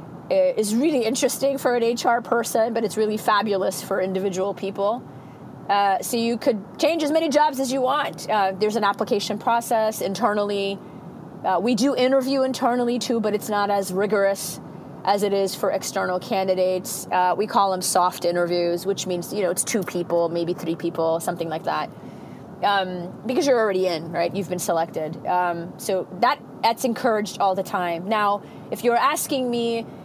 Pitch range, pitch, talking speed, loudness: 185-235 Hz, 205 Hz, 180 wpm, -23 LUFS